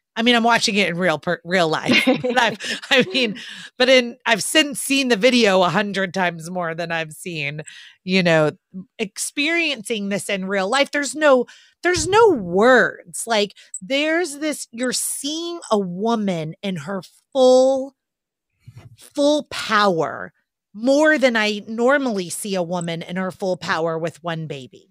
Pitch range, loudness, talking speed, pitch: 175-265 Hz, -19 LUFS, 155 wpm, 210 Hz